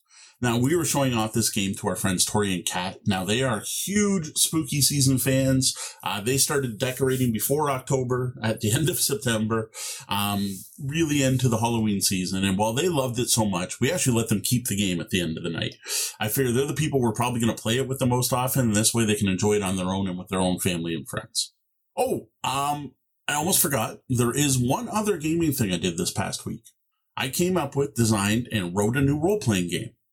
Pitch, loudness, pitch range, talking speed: 120 Hz, -24 LUFS, 105-135 Hz, 230 wpm